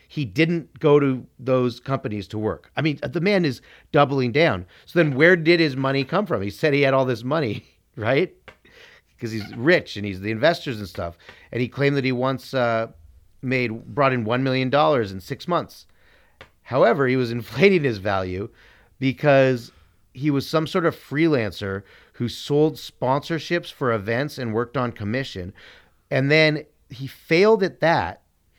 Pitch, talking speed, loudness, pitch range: 130 Hz, 175 wpm, -22 LUFS, 110-150 Hz